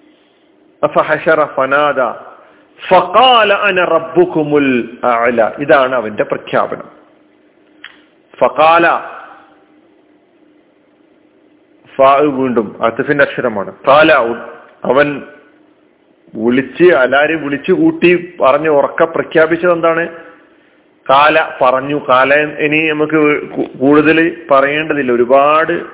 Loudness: -11 LUFS